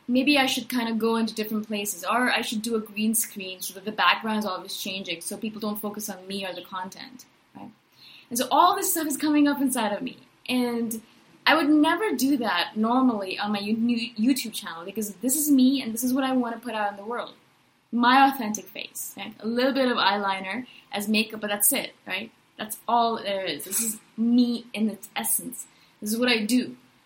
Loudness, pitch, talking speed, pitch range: -25 LUFS, 225 Hz, 220 wpm, 205-255 Hz